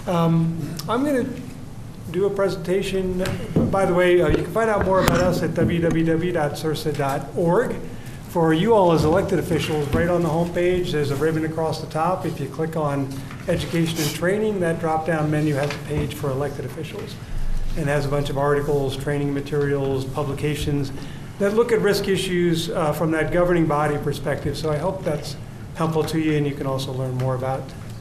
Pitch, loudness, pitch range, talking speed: 155 Hz, -22 LUFS, 145-175 Hz, 185 wpm